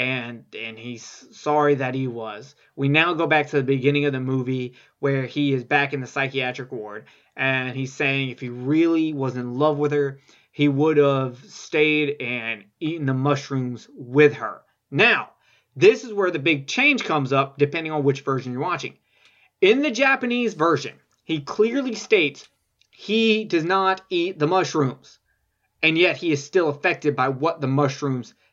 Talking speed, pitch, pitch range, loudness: 175 wpm, 145 Hz, 130-165 Hz, -21 LUFS